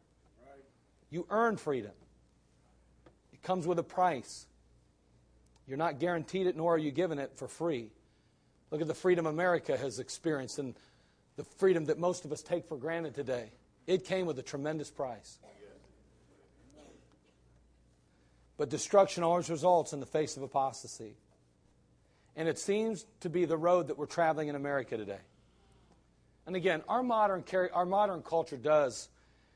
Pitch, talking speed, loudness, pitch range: 155 Hz, 150 wpm, -33 LUFS, 110-175 Hz